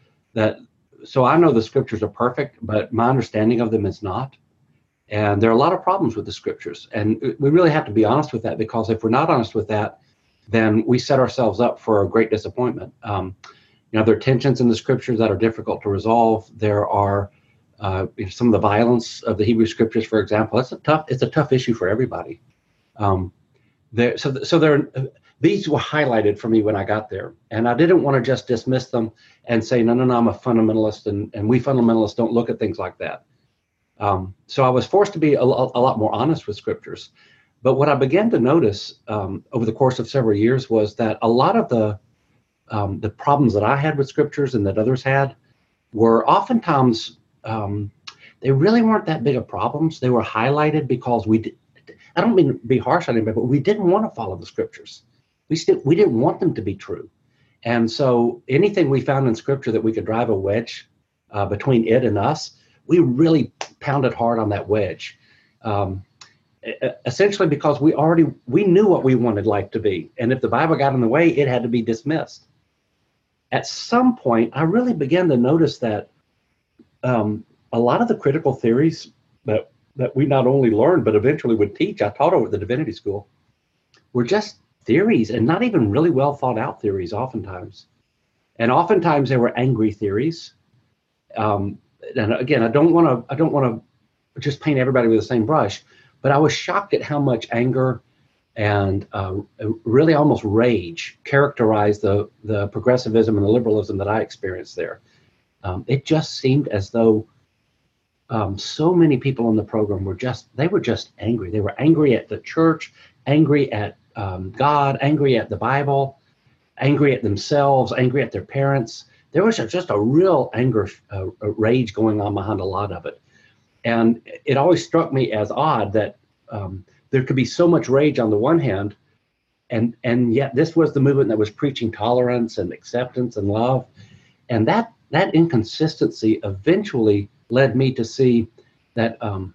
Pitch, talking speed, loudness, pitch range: 120 Hz, 195 wpm, -19 LUFS, 110-140 Hz